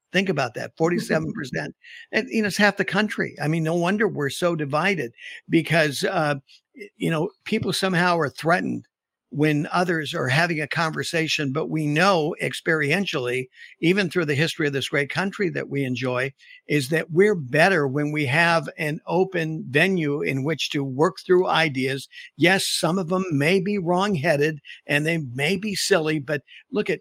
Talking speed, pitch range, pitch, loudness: 175 wpm, 145-185 Hz, 165 Hz, -22 LUFS